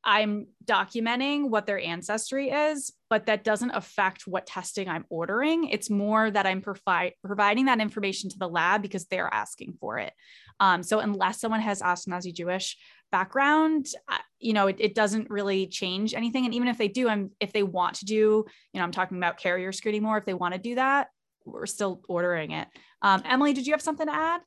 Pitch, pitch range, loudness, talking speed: 210 Hz, 190-235 Hz, -27 LUFS, 205 wpm